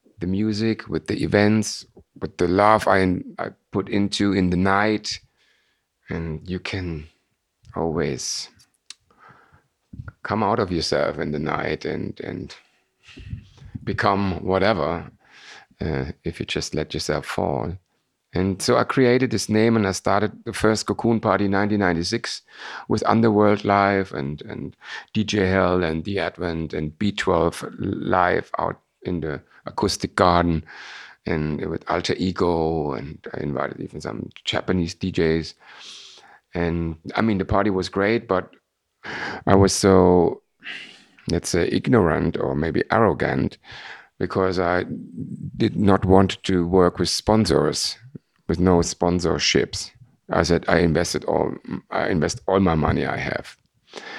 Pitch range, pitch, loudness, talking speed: 85-105 Hz, 95 Hz, -22 LUFS, 135 wpm